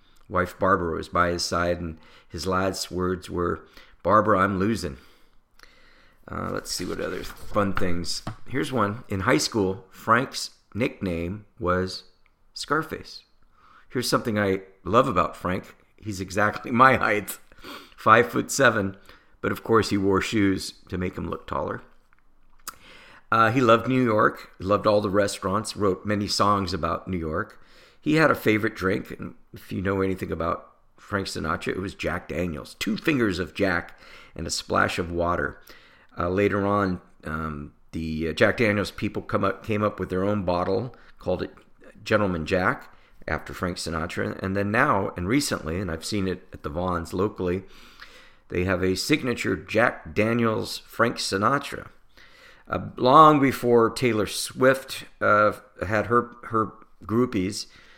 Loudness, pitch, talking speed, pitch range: -24 LUFS, 95 Hz, 155 wpm, 90-105 Hz